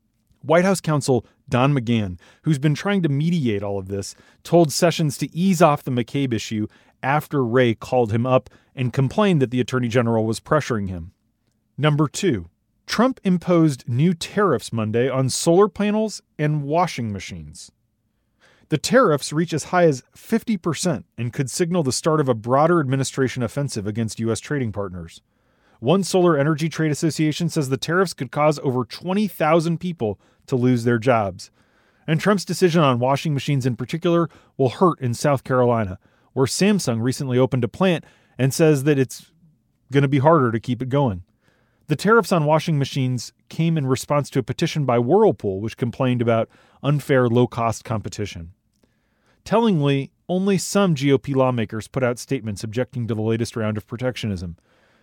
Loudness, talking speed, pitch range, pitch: -21 LUFS, 165 wpm, 115-160 Hz, 130 Hz